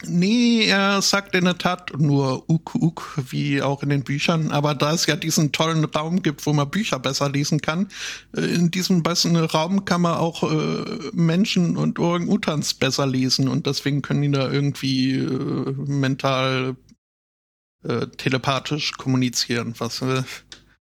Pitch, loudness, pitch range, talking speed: 150 Hz, -21 LUFS, 135-175 Hz, 155 wpm